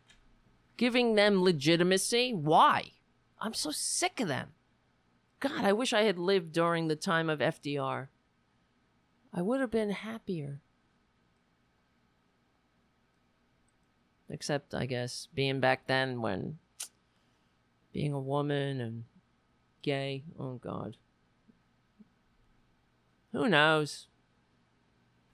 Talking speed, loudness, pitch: 95 wpm, -30 LUFS, 140 Hz